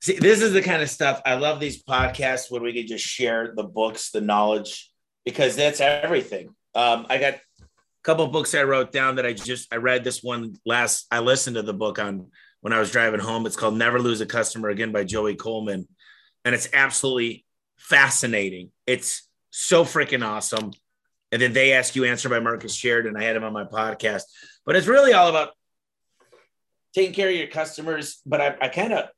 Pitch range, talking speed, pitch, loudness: 110-145 Hz, 205 wpm, 125 Hz, -22 LUFS